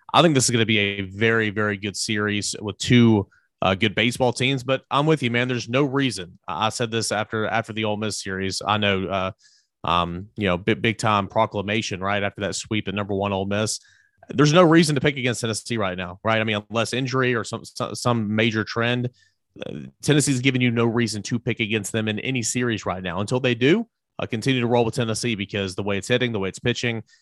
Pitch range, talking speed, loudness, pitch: 100-125 Hz, 230 wpm, -22 LUFS, 110 Hz